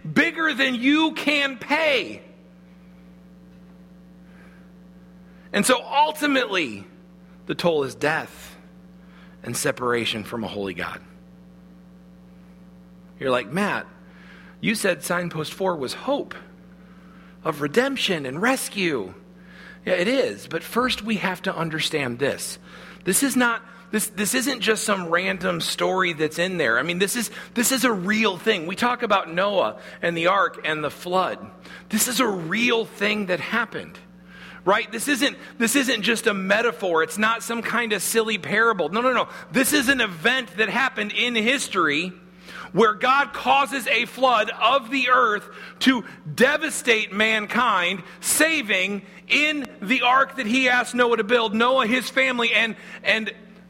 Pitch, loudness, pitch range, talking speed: 200 Hz, -22 LUFS, 180-240 Hz, 145 wpm